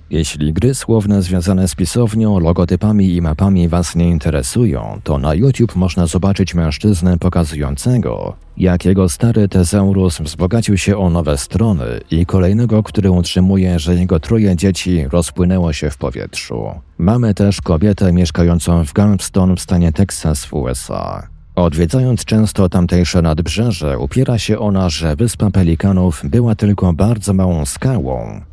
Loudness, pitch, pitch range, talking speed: -14 LUFS, 90 Hz, 85-100 Hz, 140 wpm